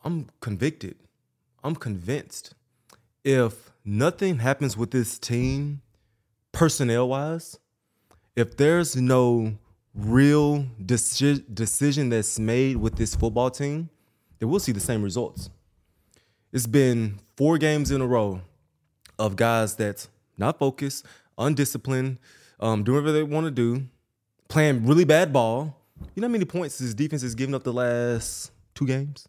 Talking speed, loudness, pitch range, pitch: 140 wpm, -24 LUFS, 110-145 Hz, 125 Hz